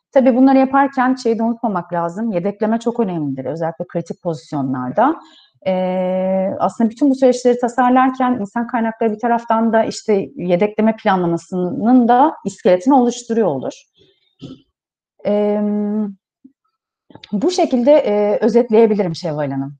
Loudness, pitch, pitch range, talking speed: -16 LUFS, 220 Hz, 185-245 Hz, 115 wpm